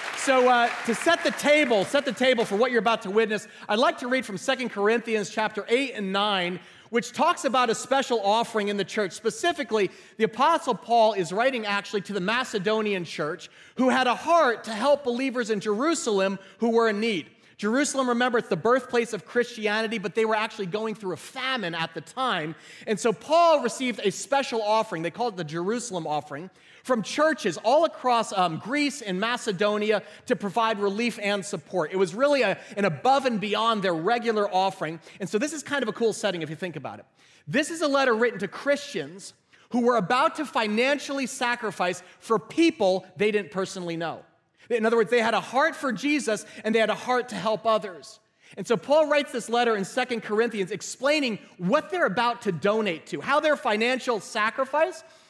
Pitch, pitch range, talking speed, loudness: 225 Hz, 200-255 Hz, 200 wpm, -25 LUFS